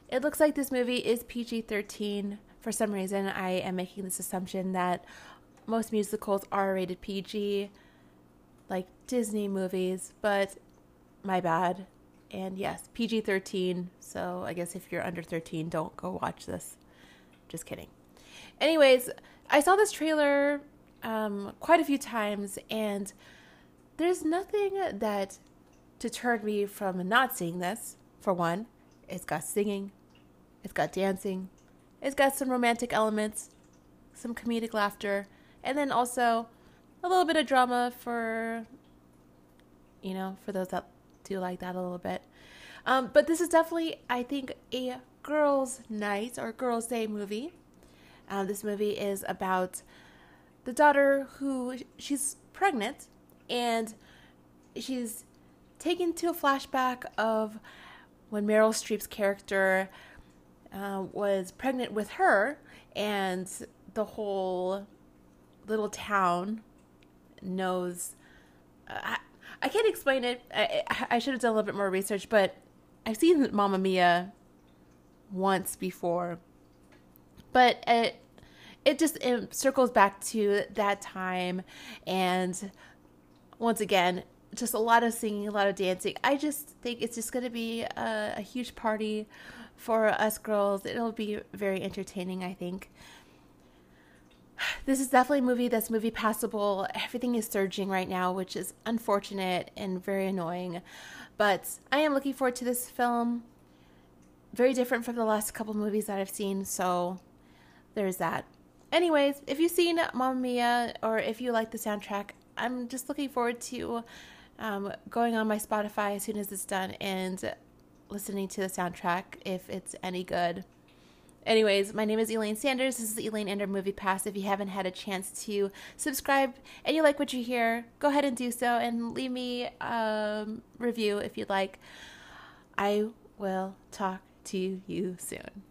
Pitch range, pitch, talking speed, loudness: 185-240 Hz, 205 Hz, 150 wpm, -30 LUFS